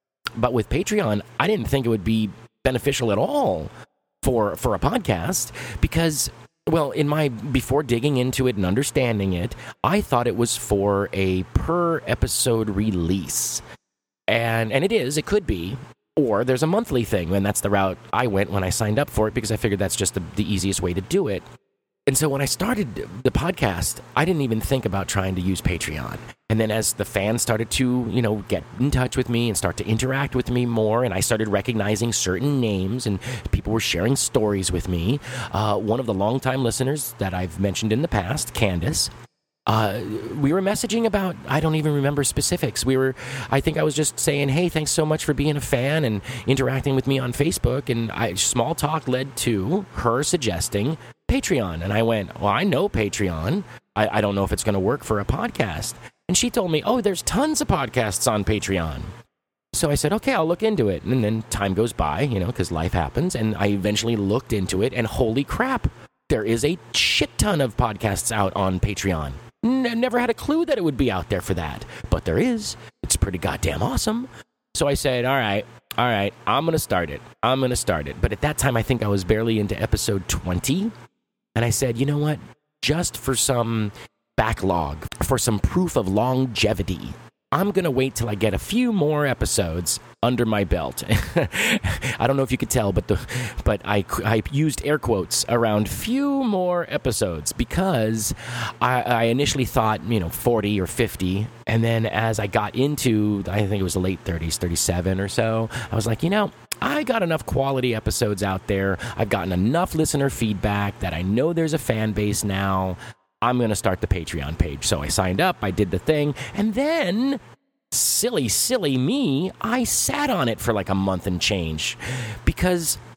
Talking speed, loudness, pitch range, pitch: 205 wpm, -22 LUFS, 100-140 Hz, 115 Hz